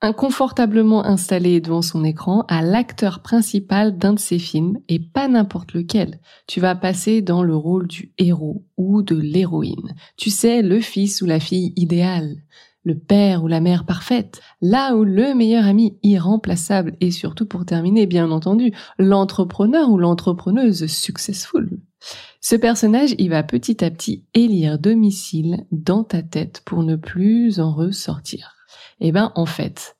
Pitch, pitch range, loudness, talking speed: 190 Hz, 170-215 Hz, -18 LUFS, 155 wpm